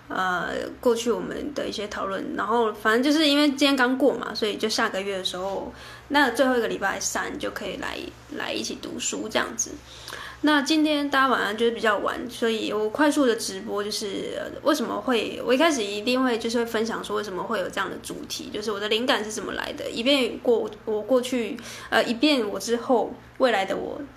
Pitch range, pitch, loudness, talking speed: 215-270 Hz, 235 Hz, -24 LUFS, 320 characters per minute